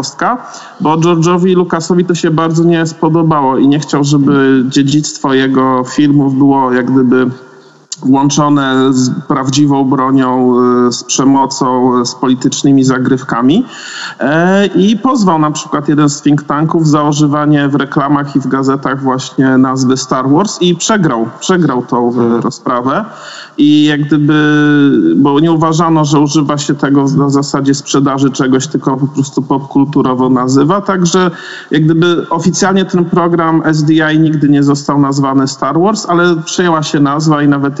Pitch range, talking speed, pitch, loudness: 135-160 Hz, 140 wpm, 145 Hz, -10 LUFS